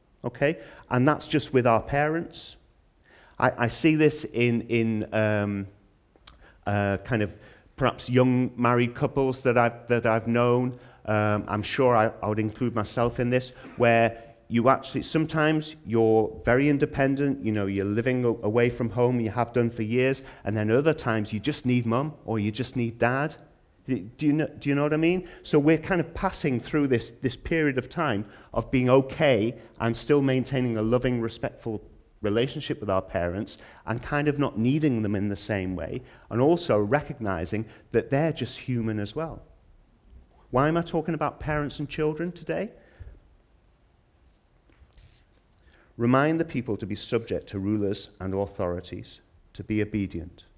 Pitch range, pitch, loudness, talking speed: 105-140 Hz, 120 Hz, -26 LUFS, 170 wpm